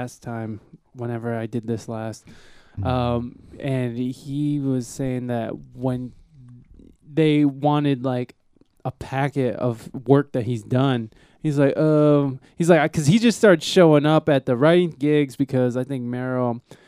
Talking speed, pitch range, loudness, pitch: 150 wpm, 120-145 Hz, -21 LUFS, 130 Hz